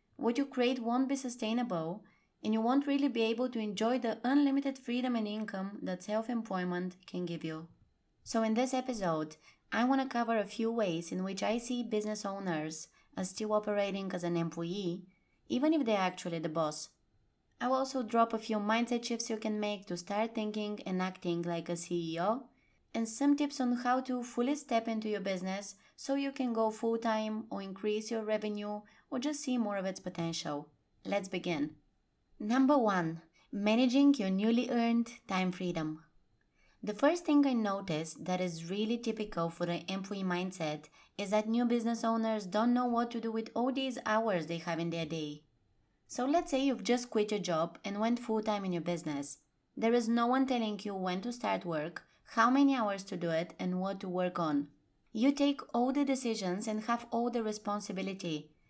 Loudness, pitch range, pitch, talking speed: -34 LUFS, 180-240 Hz, 215 Hz, 190 wpm